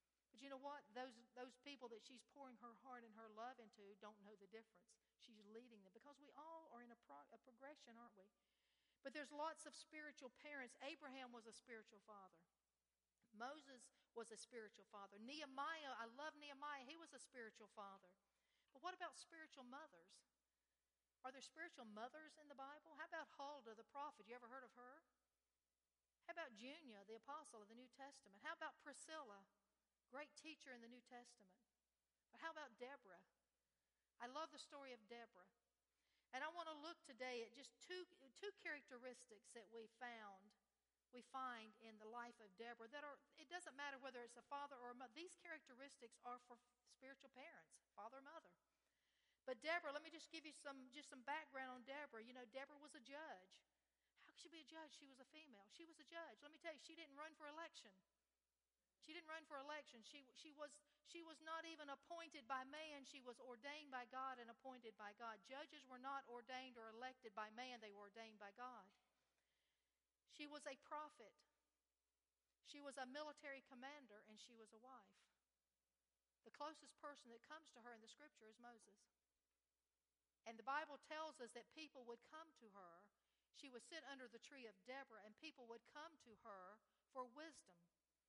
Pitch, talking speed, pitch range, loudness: 255 Hz, 190 wpm, 225-295 Hz, -58 LUFS